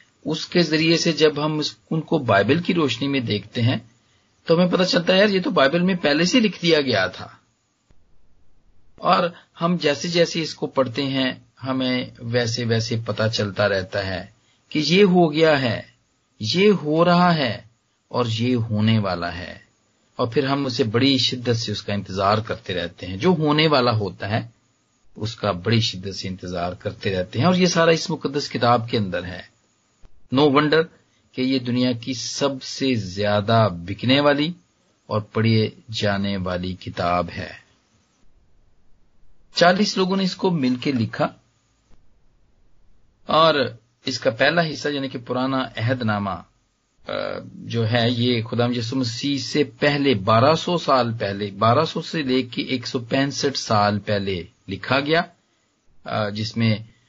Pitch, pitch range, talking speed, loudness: 120 Hz, 105-145 Hz, 145 wpm, -21 LUFS